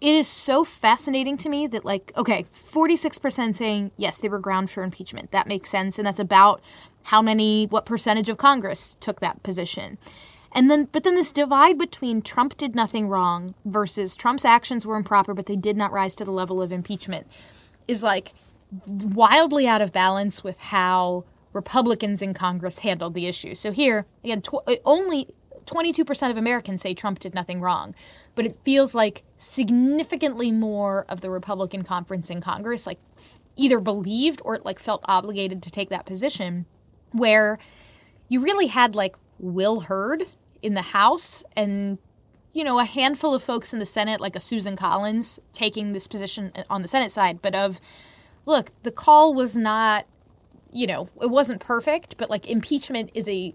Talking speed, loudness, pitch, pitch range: 180 wpm, -22 LUFS, 215 Hz, 195-255 Hz